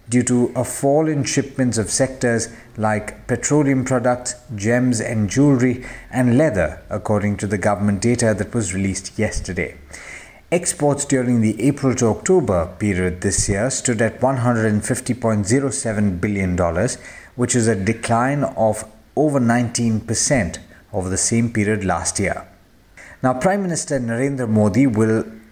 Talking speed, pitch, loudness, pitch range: 135 wpm, 115 Hz, -19 LUFS, 105-130 Hz